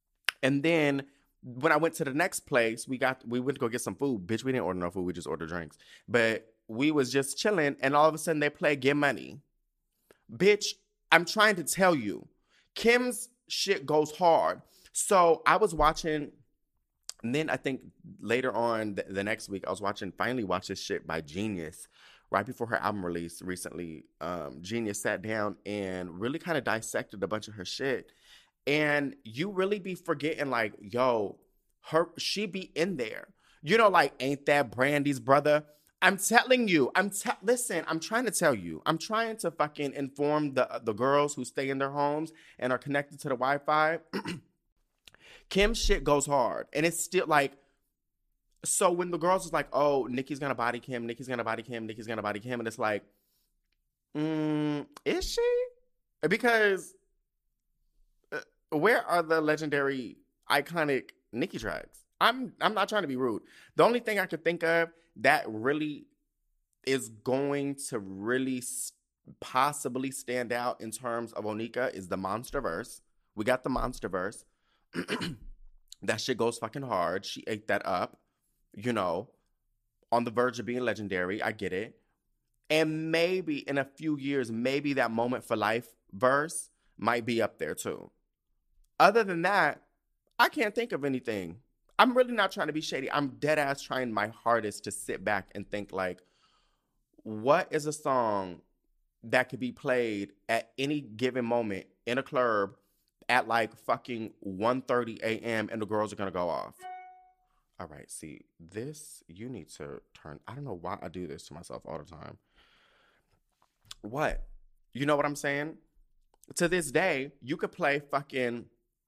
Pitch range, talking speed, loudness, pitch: 115-160 Hz, 175 wpm, -30 LUFS, 135 Hz